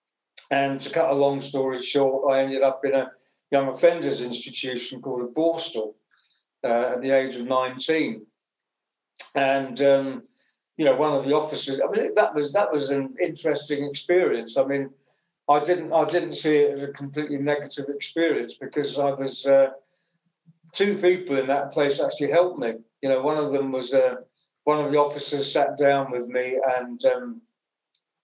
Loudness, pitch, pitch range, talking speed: -24 LUFS, 140 Hz, 135-150 Hz, 175 wpm